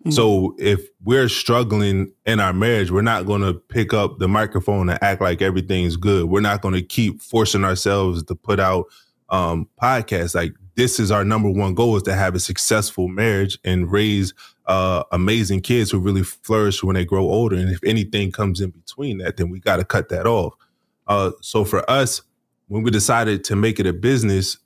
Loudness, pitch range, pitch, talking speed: -19 LUFS, 95-110 Hz, 100 Hz, 195 wpm